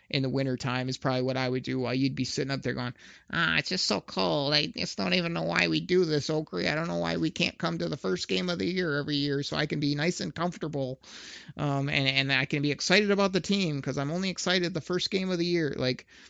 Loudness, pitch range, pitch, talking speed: -28 LUFS, 130-175 Hz, 145 Hz, 275 wpm